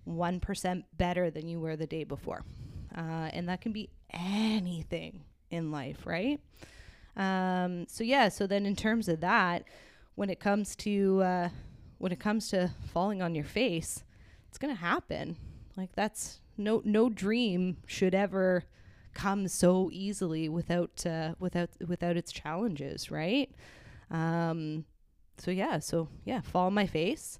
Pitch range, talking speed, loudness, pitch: 160-200 Hz, 155 wpm, -32 LUFS, 180 Hz